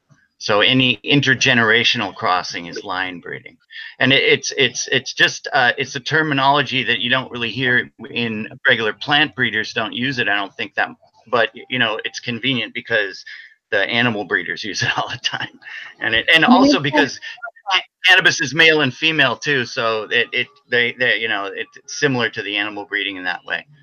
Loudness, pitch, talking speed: -17 LUFS, 135 Hz, 185 wpm